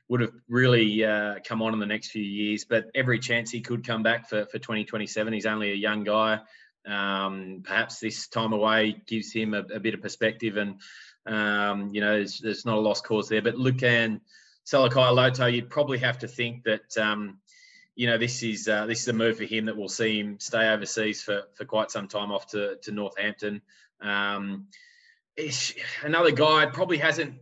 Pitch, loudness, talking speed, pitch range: 110 Hz, -26 LUFS, 195 wpm, 105-120 Hz